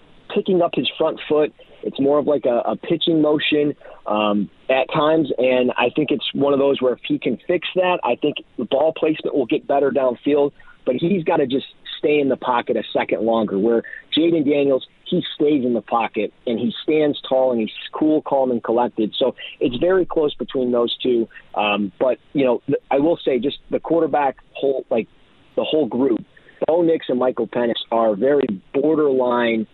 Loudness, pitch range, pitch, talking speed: -20 LUFS, 120-155 Hz, 140 Hz, 200 wpm